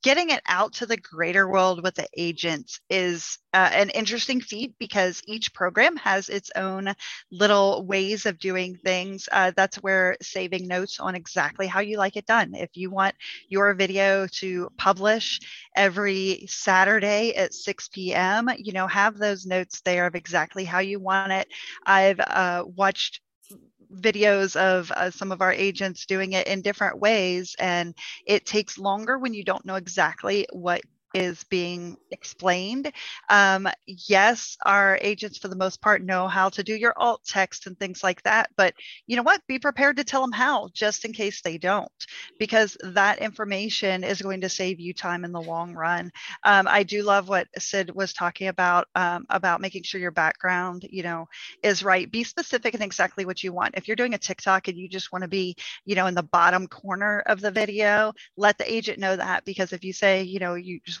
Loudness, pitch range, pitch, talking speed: -24 LUFS, 185-205 Hz, 195 Hz, 195 wpm